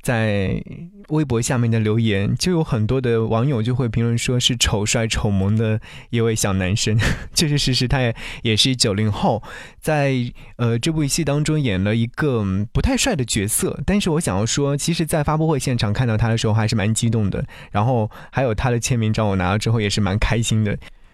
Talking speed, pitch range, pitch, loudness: 300 characters per minute, 110-140 Hz, 115 Hz, -20 LUFS